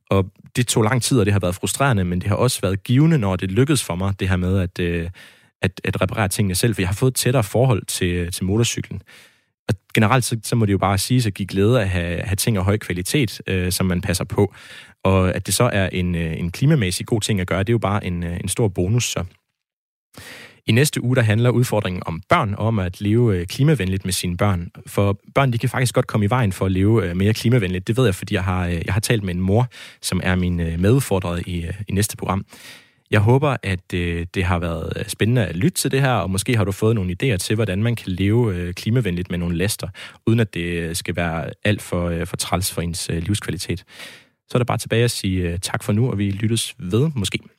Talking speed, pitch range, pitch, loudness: 240 wpm, 90-120 Hz, 100 Hz, -20 LUFS